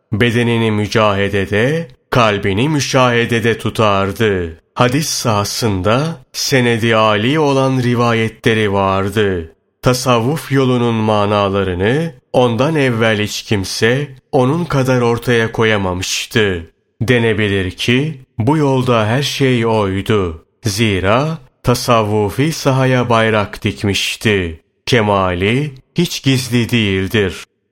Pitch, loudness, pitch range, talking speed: 115 Hz, -15 LUFS, 105-130 Hz, 85 wpm